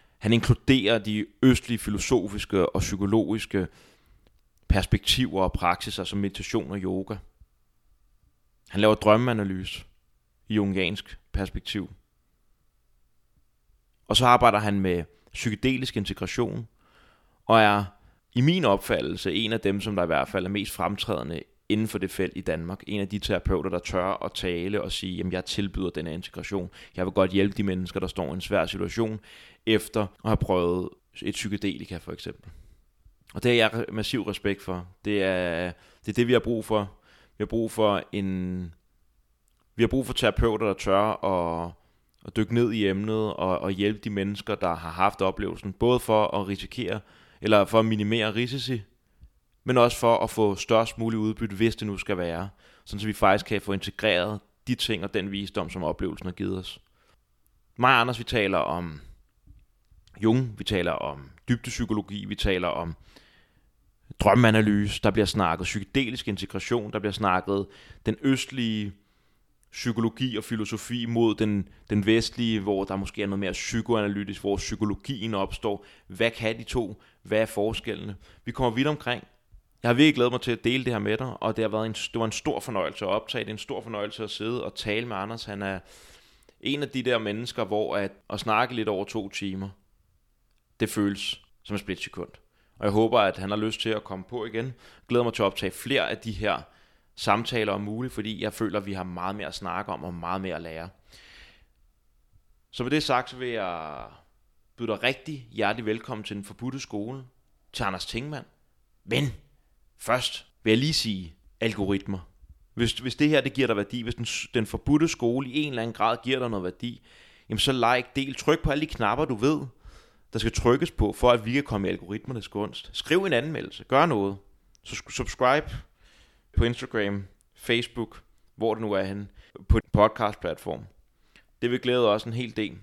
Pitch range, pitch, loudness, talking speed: 95-115 Hz, 105 Hz, -27 LUFS, 185 wpm